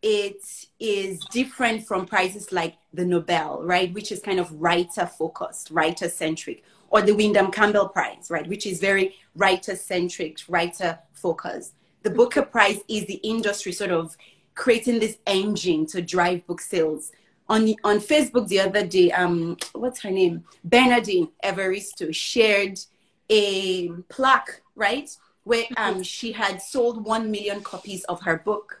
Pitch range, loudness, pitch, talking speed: 175-220 Hz, -23 LUFS, 195 Hz, 150 wpm